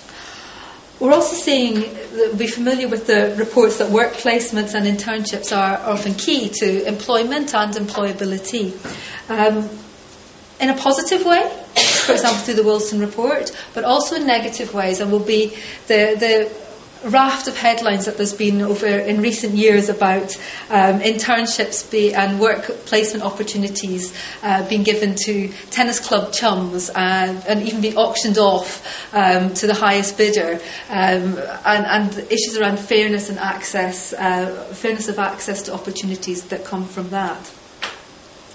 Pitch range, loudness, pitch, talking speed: 195-225 Hz, -18 LUFS, 210 Hz, 150 wpm